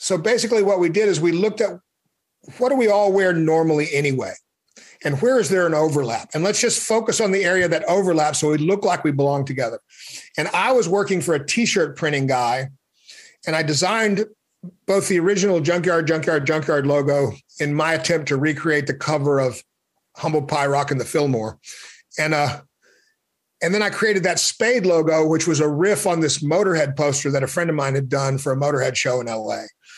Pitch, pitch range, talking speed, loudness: 160 Hz, 145-195 Hz, 200 wpm, -20 LUFS